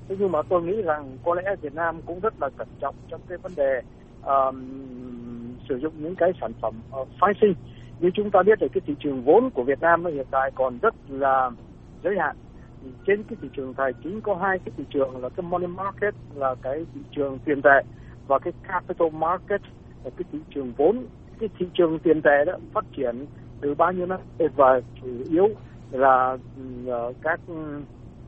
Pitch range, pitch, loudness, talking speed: 130-180 Hz, 150 Hz, -24 LUFS, 205 wpm